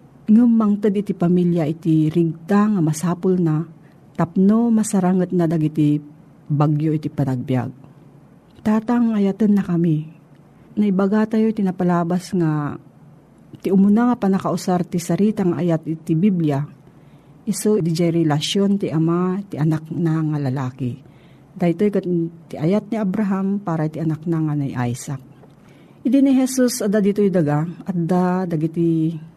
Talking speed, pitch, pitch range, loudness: 145 wpm, 170 Hz, 155-200 Hz, -19 LUFS